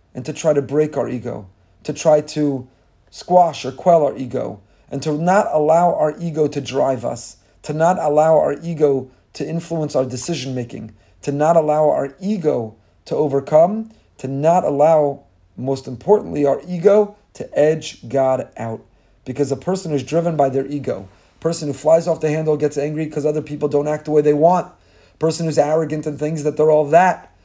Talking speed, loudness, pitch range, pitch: 190 wpm, -18 LUFS, 135-160 Hz, 150 Hz